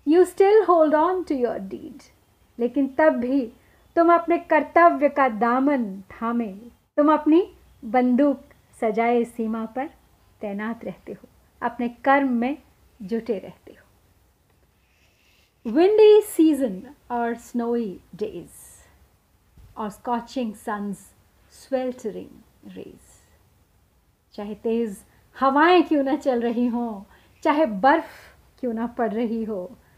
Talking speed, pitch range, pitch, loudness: 110 wpm, 205-285 Hz, 240 Hz, -22 LUFS